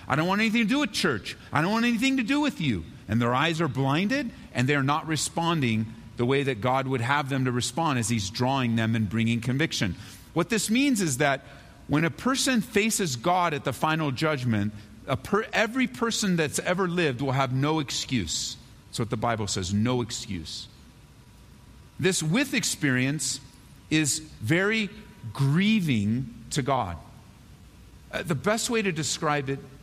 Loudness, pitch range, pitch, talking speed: -26 LUFS, 125-180 Hz, 140 Hz, 175 wpm